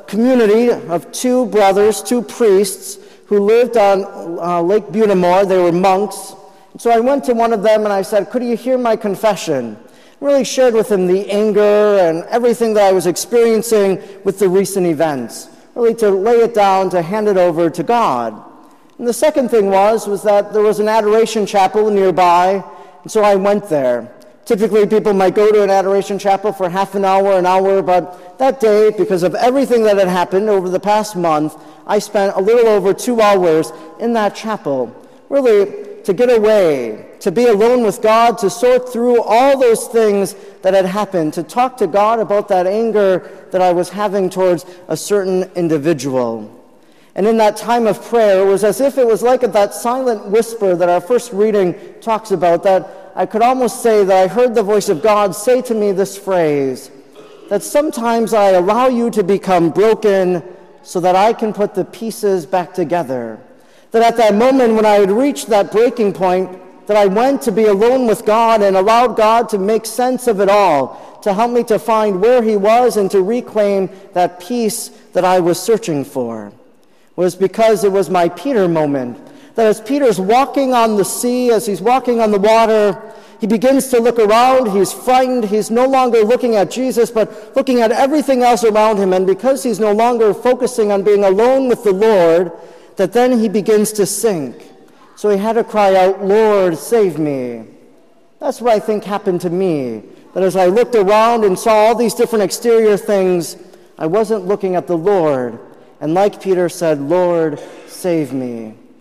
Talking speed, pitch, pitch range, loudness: 190 wpm, 210 Hz, 190-230 Hz, -14 LUFS